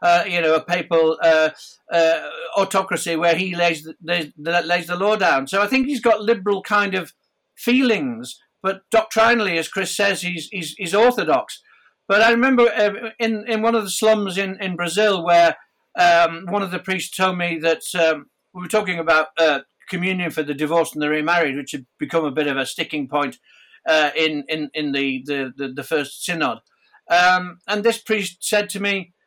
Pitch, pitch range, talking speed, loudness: 175 Hz, 160-205 Hz, 195 wpm, -19 LUFS